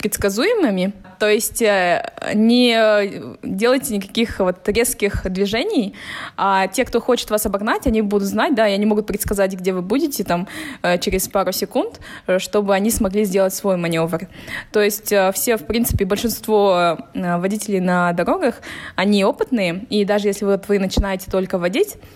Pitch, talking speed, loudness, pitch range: 205 Hz, 150 wpm, -18 LUFS, 190-225 Hz